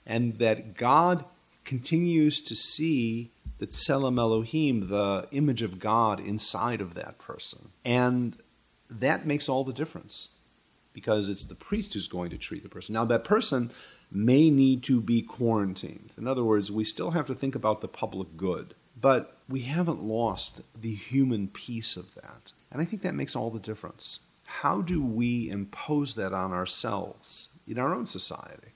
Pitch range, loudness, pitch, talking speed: 110-135 Hz, -28 LUFS, 115 Hz, 170 wpm